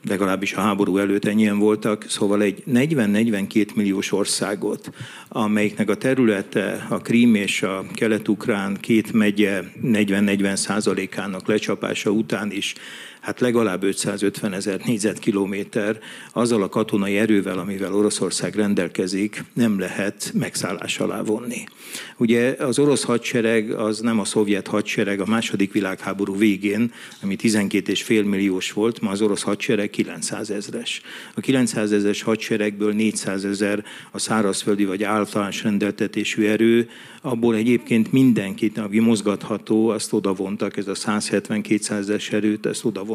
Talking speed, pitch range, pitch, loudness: 125 wpm, 100-110 Hz, 105 Hz, -21 LUFS